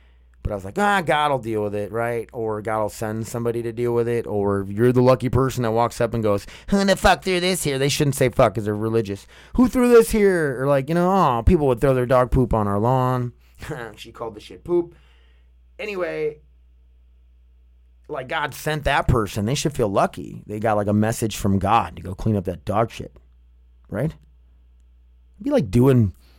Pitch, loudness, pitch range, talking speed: 115 Hz, -21 LUFS, 95-135 Hz, 215 wpm